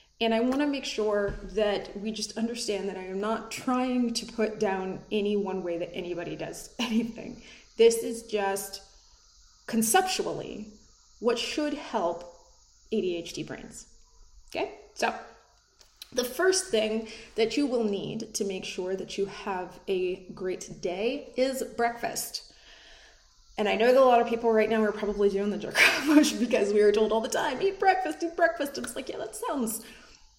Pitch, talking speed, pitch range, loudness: 220 Hz, 170 wpm, 200-245 Hz, -28 LUFS